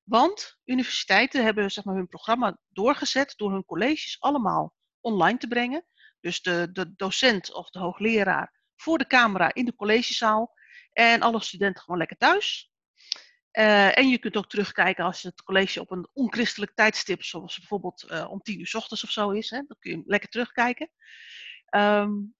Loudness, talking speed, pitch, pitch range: -24 LUFS, 170 wpm, 215 Hz, 190-245 Hz